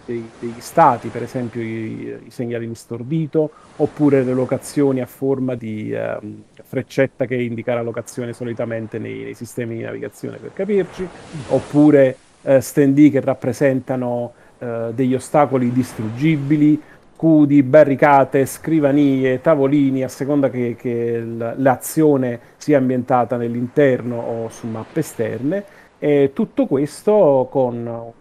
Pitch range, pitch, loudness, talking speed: 120-145 Hz, 130 Hz, -18 LUFS, 125 wpm